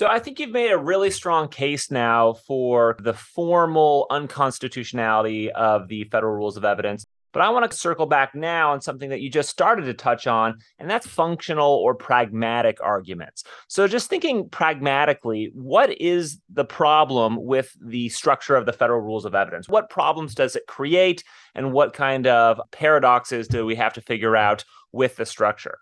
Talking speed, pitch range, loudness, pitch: 180 wpm, 115-165 Hz, -21 LUFS, 140 Hz